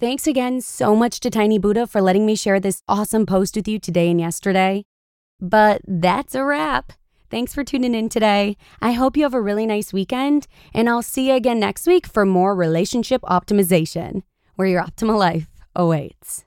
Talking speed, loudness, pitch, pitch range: 190 wpm, -19 LUFS, 210 Hz, 190-245 Hz